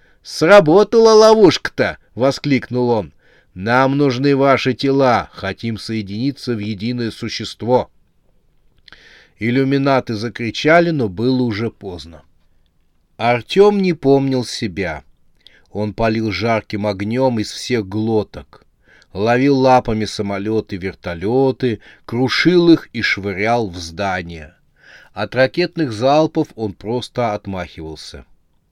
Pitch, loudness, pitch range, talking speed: 115 Hz, -16 LUFS, 105-135 Hz, 95 wpm